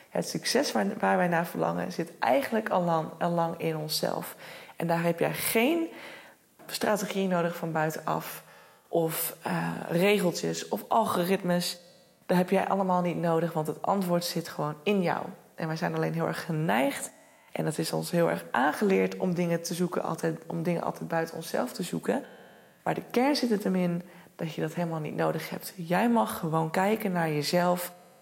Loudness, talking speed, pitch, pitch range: -29 LUFS, 175 wpm, 175 Hz, 160-185 Hz